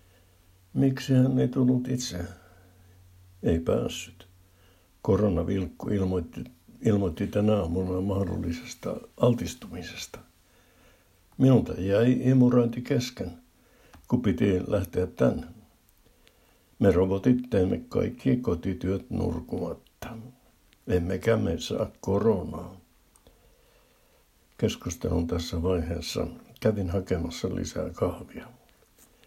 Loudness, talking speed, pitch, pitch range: -27 LUFS, 80 wpm, 95 Hz, 90-115 Hz